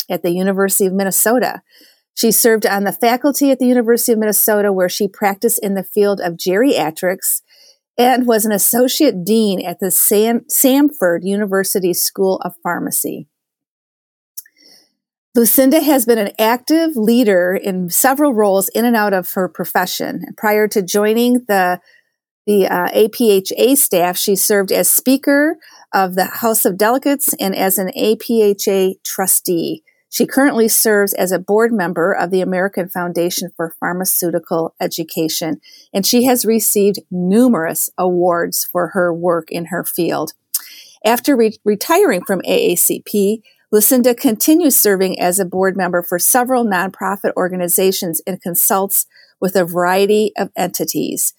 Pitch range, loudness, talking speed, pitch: 185-240 Hz, -14 LUFS, 140 wpm, 205 Hz